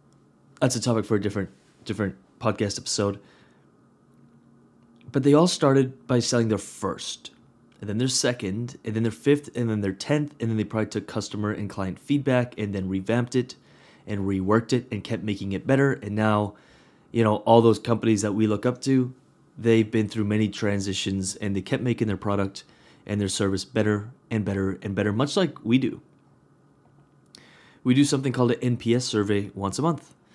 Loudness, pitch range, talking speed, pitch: -25 LUFS, 100-125 Hz, 190 wpm, 110 Hz